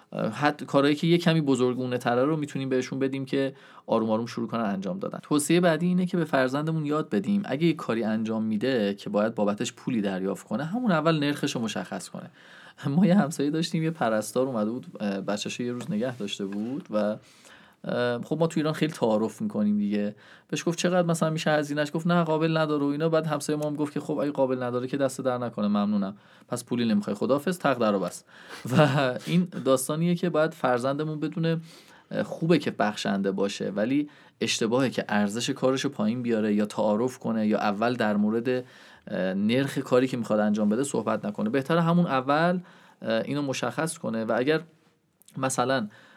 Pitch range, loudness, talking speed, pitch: 115-165 Hz, -26 LUFS, 185 wpm, 140 Hz